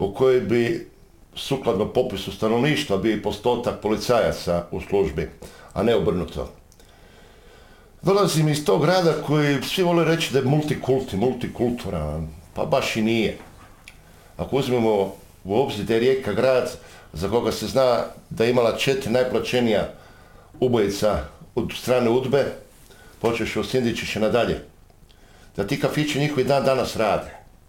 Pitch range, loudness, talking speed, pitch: 95-130 Hz, -22 LUFS, 135 wpm, 110 Hz